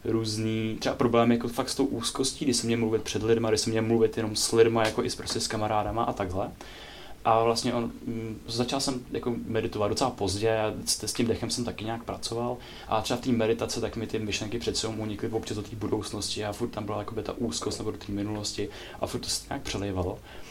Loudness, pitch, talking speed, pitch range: -28 LUFS, 110 Hz, 240 wpm, 105-115 Hz